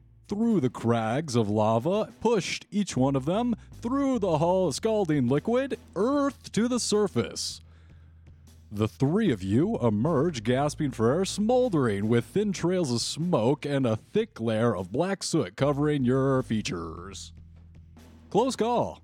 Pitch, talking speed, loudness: 135 Hz, 140 wpm, -27 LUFS